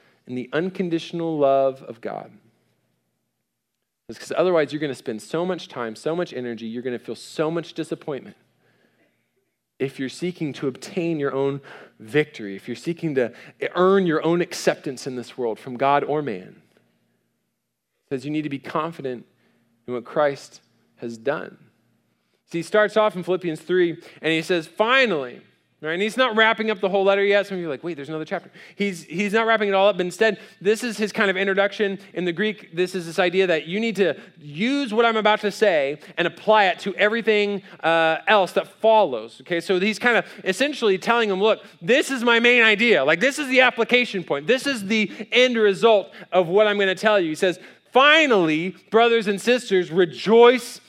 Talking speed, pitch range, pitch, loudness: 200 wpm, 155-215 Hz, 185 Hz, -21 LUFS